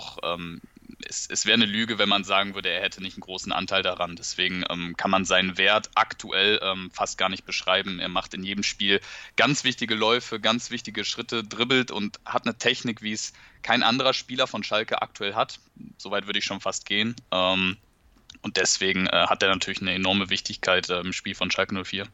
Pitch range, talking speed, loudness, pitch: 95-115 Hz, 185 wpm, -24 LUFS, 100 Hz